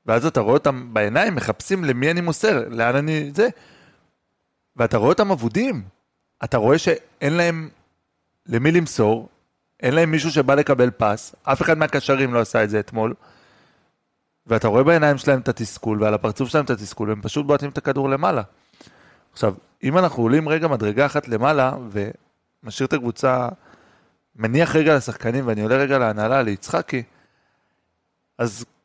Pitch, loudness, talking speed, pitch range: 135 Hz, -20 LUFS, 150 wpm, 115-155 Hz